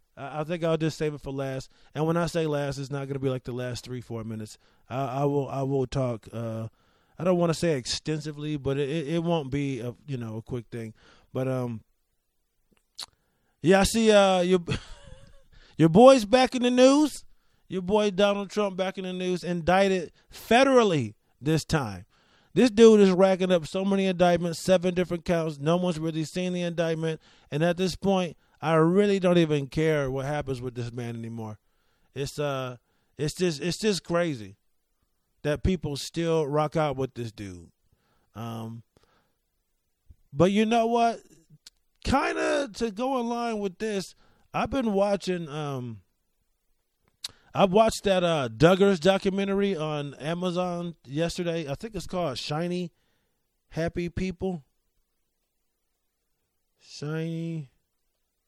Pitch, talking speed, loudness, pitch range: 160 Hz, 160 wpm, -26 LUFS, 130-185 Hz